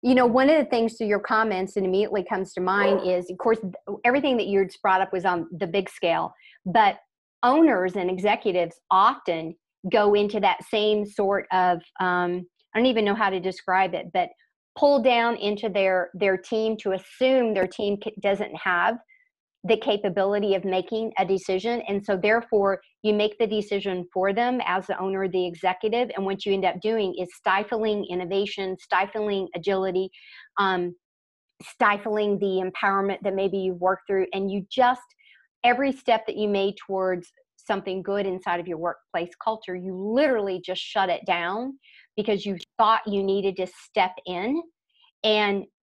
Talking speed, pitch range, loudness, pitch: 170 wpm, 185-220 Hz, -24 LUFS, 200 Hz